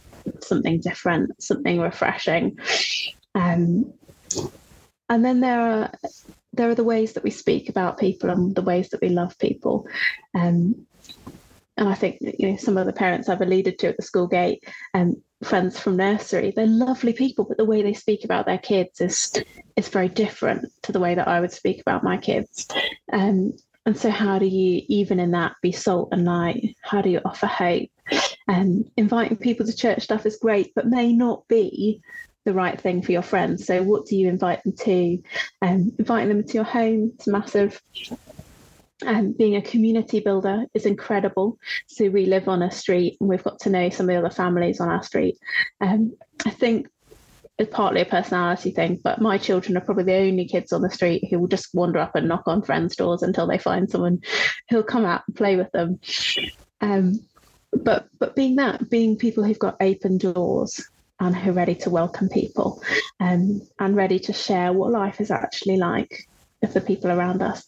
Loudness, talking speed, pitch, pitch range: -22 LUFS, 200 wpm, 200 Hz, 185-225 Hz